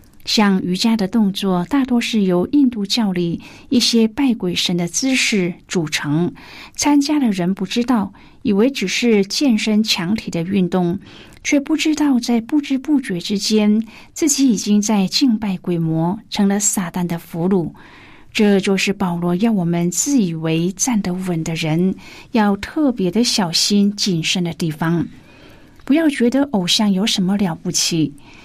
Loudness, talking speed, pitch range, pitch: -17 LUFS, 230 characters per minute, 180-235 Hz, 200 Hz